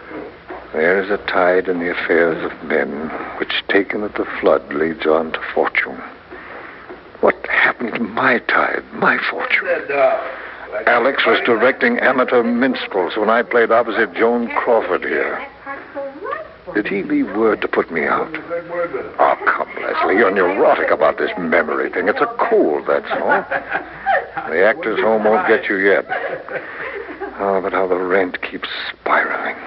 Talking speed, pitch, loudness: 150 wpm, 275 Hz, -17 LUFS